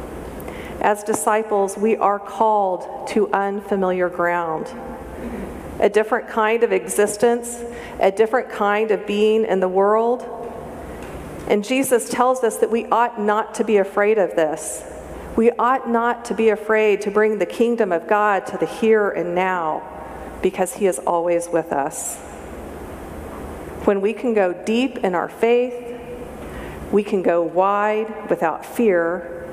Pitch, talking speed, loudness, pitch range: 210 Hz, 145 wpm, -20 LUFS, 185-230 Hz